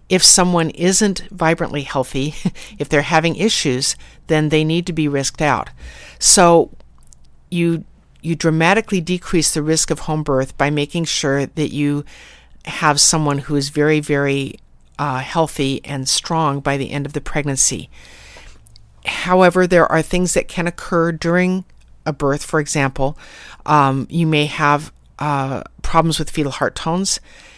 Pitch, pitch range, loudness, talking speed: 150 Hz, 140-170 Hz, -17 LUFS, 150 wpm